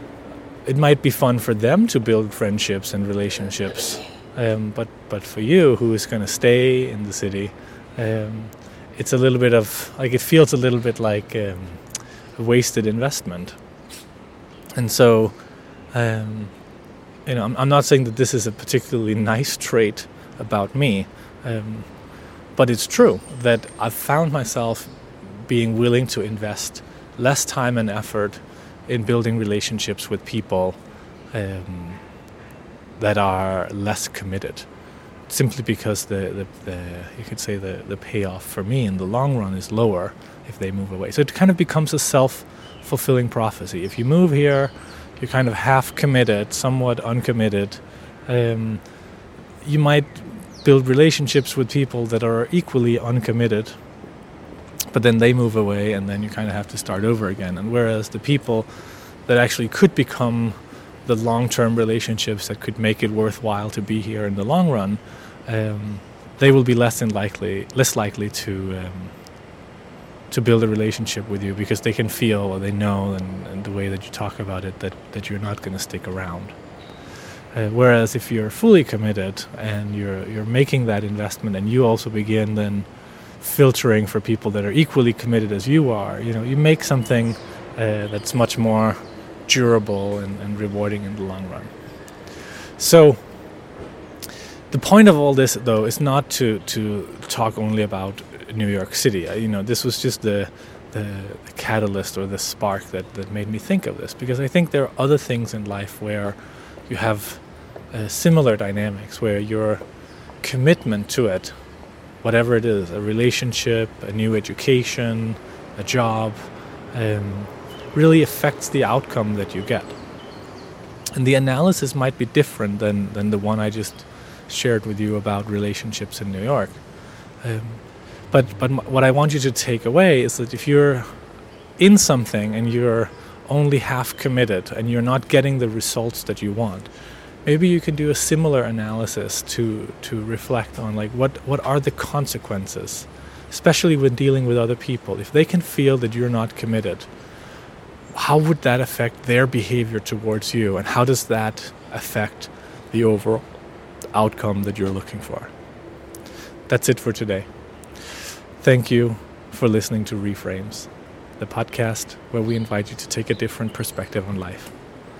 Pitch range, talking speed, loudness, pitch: 105-125 Hz, 165 wpm, -20 LUFS, 115 Hz